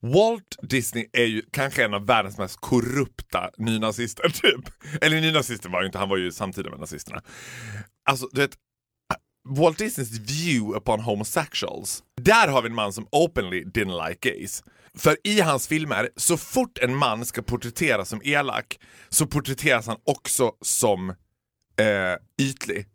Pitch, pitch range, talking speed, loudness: 125 Hz, 110-145 Hz, 155 wpm, -24 LUFS